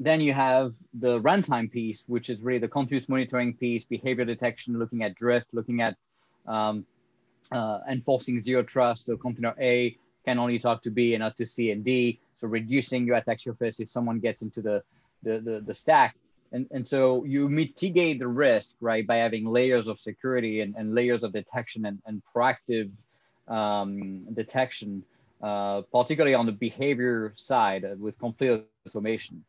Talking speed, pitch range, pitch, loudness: 175 wpm, 110-125 Hz, 120 Hz, -27 LUFS